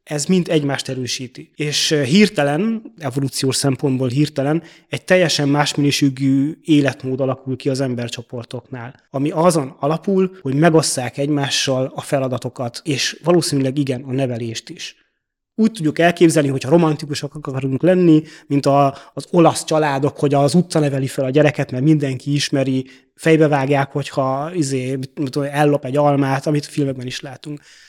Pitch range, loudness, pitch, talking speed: 135-155 Hz, -18 LUFS, 145 Hz, 140 wpm